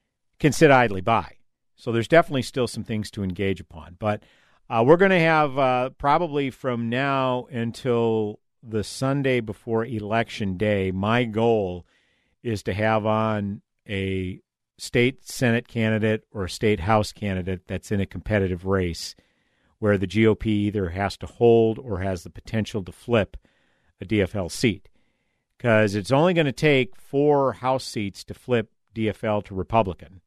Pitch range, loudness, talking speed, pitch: 100-120 Hz, -23 LUFS, 155 wpm, 110 Hz